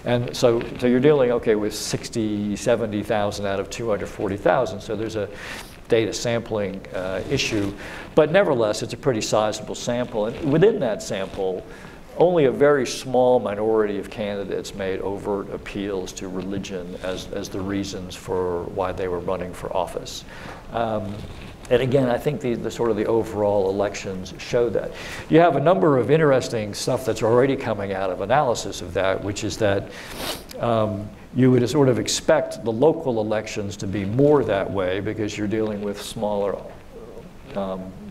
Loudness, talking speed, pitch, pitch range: -22 LUFS, 165 wpm, 105 Hz, 100-120 Hz